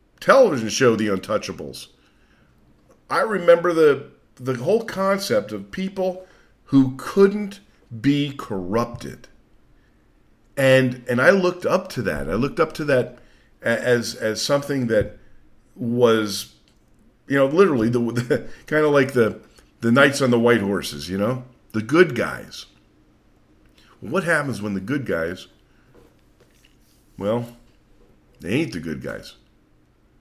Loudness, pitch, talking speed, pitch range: -21 LUFS, 125 Hz, 130 wpm, 110-145 Hz